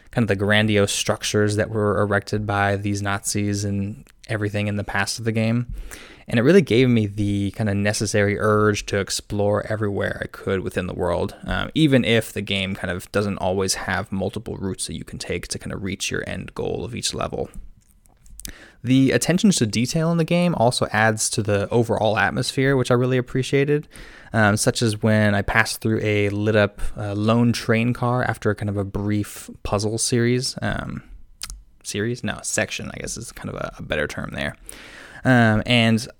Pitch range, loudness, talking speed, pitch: 100-120 Hz, -21 LUFS, 195 wpm, 105 Hz